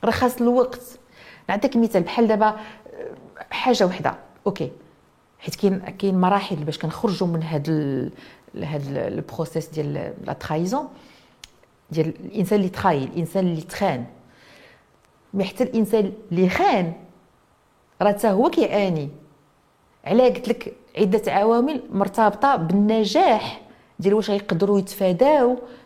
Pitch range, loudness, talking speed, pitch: 170-230 Hz, -22 LUFS, 110 wpm, 200 Hz